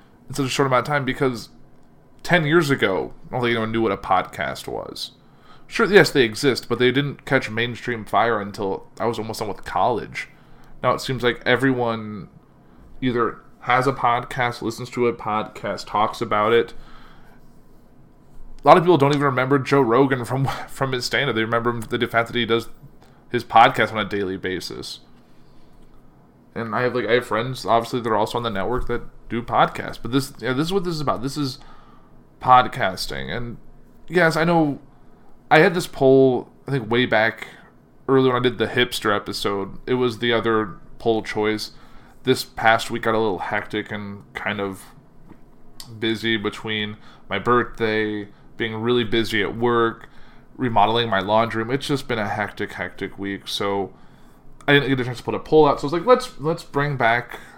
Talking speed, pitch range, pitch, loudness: 190 wpm, 110-135 Hz, 120 Hz, -21 LUFS